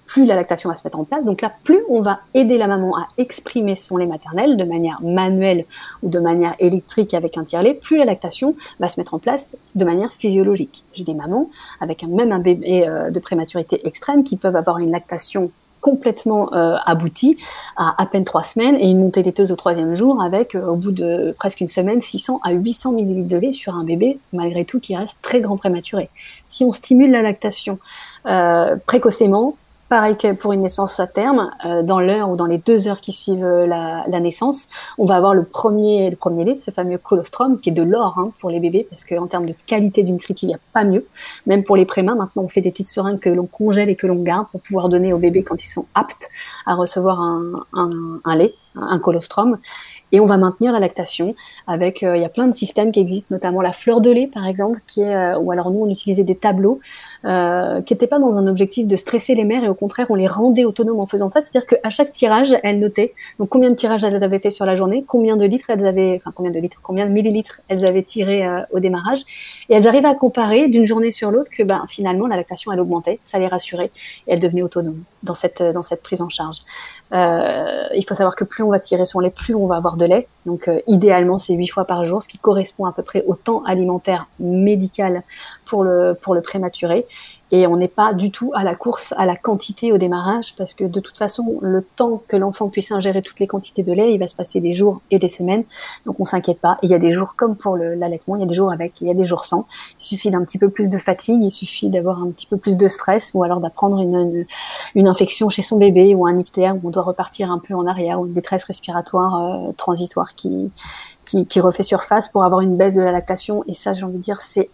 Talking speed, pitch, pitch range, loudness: 245 wpm, 195 Hz, 180-215 Hz, -17 LUFS